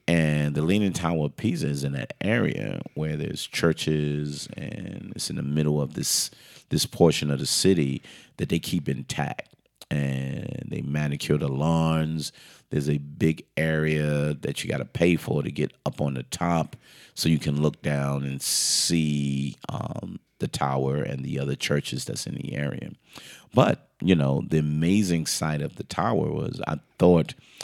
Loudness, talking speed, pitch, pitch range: -26 LUFS, 175 wpm, 75 Hz, 70-80 Hz